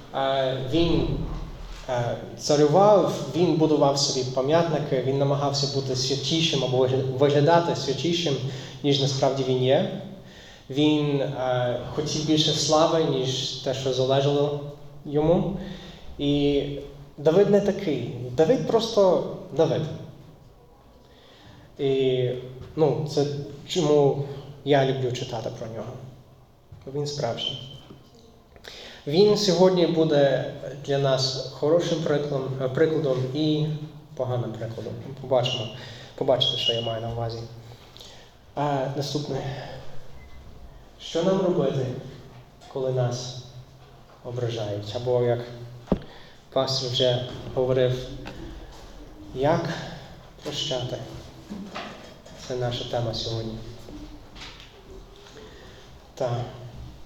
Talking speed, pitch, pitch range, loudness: 85 wpm, 135 Hz, 125-150 Hz, -24 LUFS